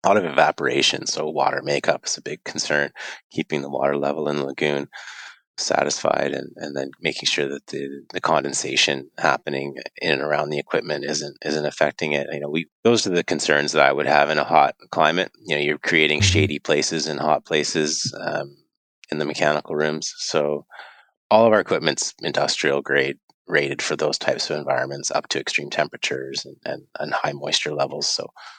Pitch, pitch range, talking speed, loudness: 75 Hz, 70-80 Hz, 190 wpm, -22 LUFS